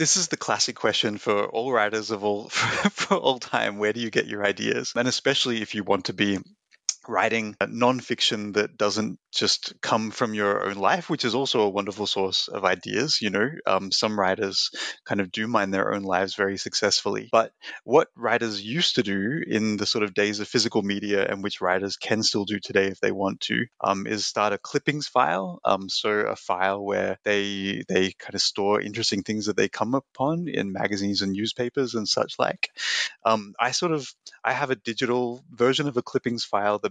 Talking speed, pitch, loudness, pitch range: 210 wpm, 110 Hz, -25 LUFS, 100-125 Hz